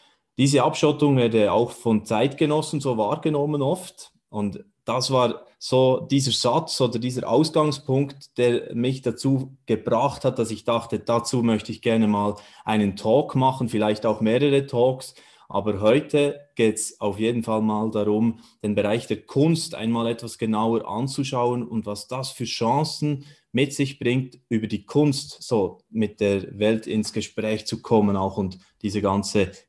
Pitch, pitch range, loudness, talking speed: 120 Hz, 110-140 Hz, -23 LUFS, 160 wpm